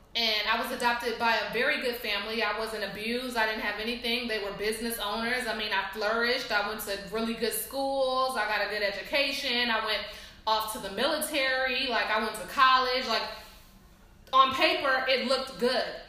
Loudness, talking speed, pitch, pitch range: -28 LUFS, 195 wpm, 225 Hz, 215-260 Hz